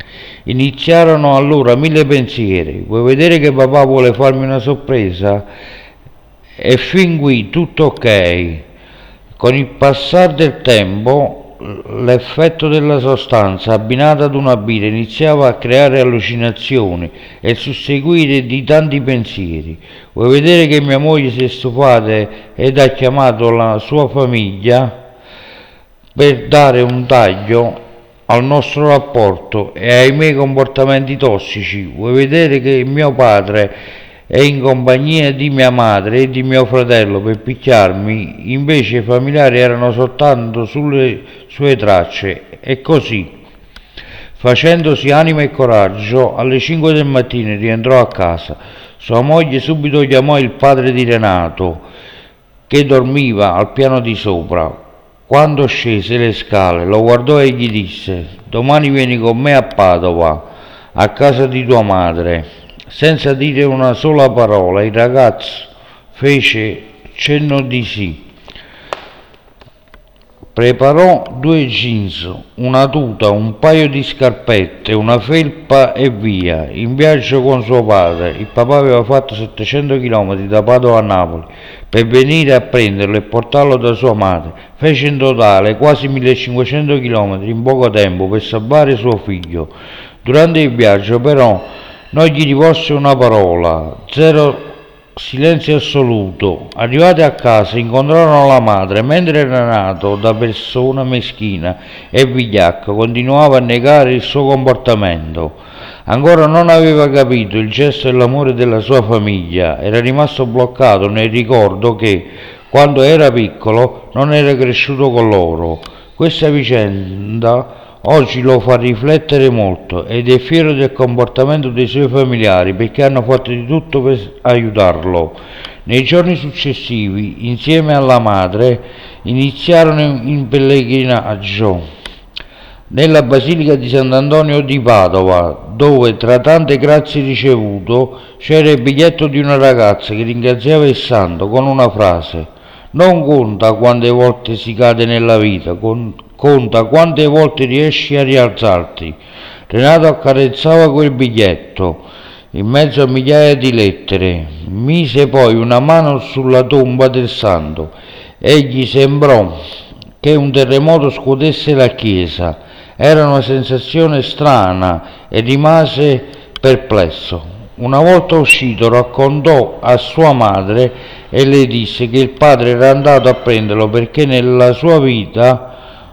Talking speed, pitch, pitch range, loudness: 130 wpm, 125 Hz, 110-140 Hz, -10 LUFS